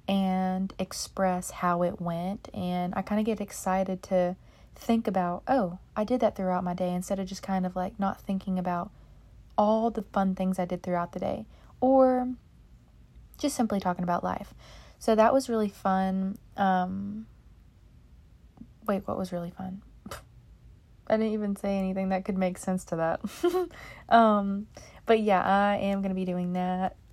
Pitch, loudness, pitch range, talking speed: 190 Hz, -28 LUFS, 185-210 Hz, 170 wpm